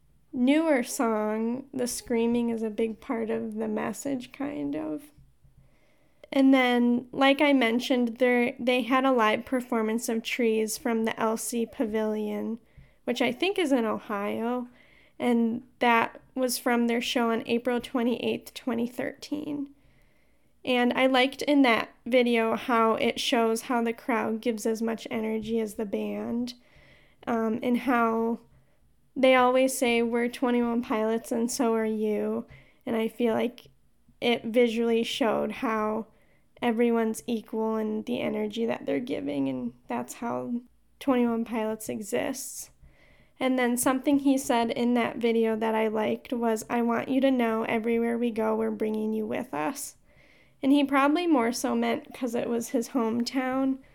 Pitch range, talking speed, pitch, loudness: 225-255 Hz, 150 wpm, 235 Hz, -27 LUFS